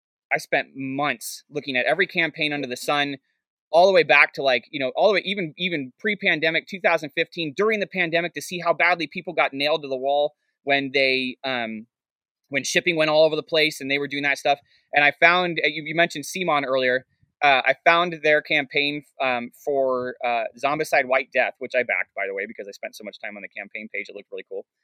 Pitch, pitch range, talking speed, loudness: 150 Hz, 140-170 Hz, 225 wpm, -22 LUFS